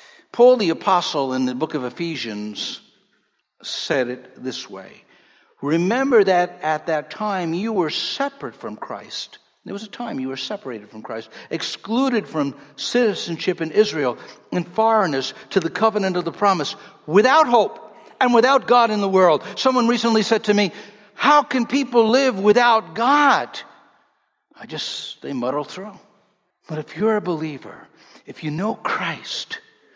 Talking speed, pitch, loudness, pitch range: 155 wpm, 200 Hz, -20 LUFS, 155-235 Hz